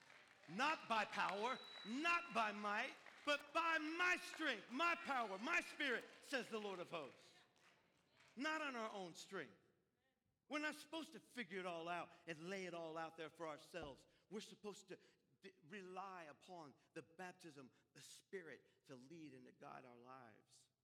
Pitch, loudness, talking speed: 195 Hz, -46 LUFS, 165 wpm